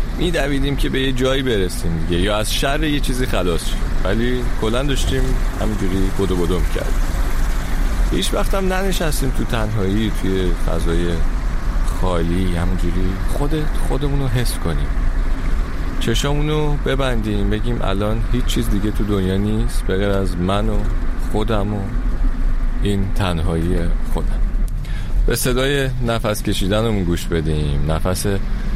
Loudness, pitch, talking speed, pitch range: -21 LUFS, 100 Hz, 130 wpm, 85-120 Hz